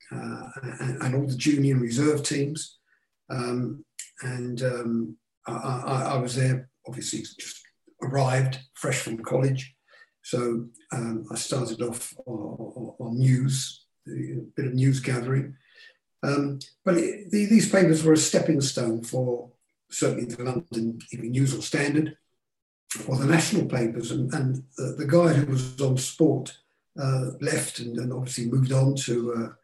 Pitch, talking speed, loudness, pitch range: 130 Hz, 155 wpm, -26 LUFS, 120-145 Hz